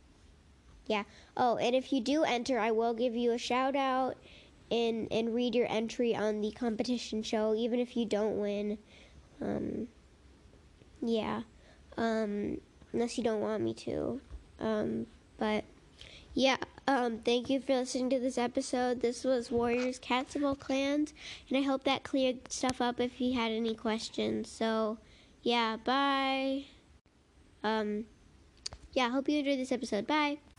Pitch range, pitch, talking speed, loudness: 220-260 Hz, 240 Hz, 155 wpm, -33 LUFS